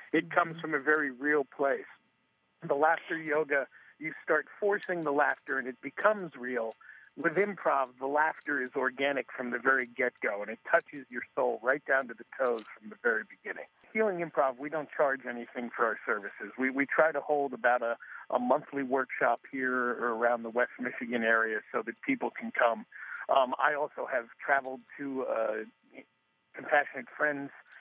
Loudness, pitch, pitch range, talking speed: -31 LUFS, 140 Hz, 125-155 Hz, 180 wpm